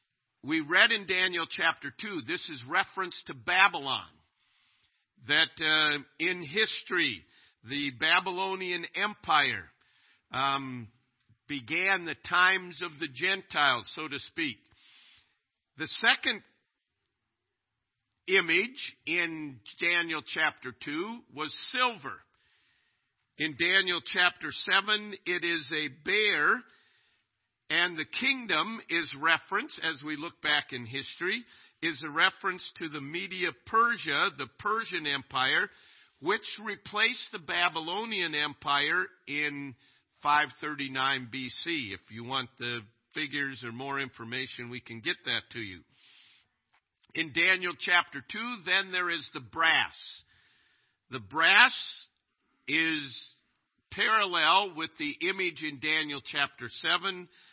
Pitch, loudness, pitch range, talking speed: 160 Hz, -28 LUFS, 140-185 Hz, 115 wpm